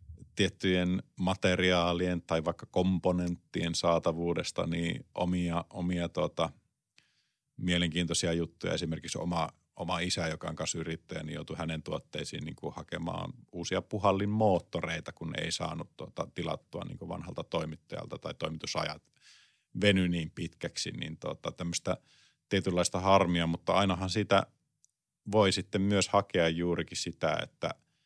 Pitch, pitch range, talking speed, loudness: 90 Hz, 85-95 Hz, 125 wpm, -32 LUFS